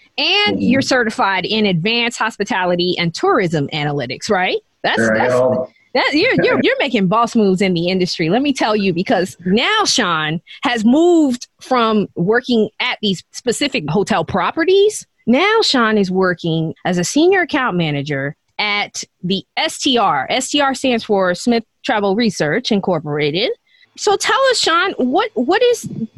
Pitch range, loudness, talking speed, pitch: 180-280 Hz, -16 LUFS, 150 wpm, 220 Hz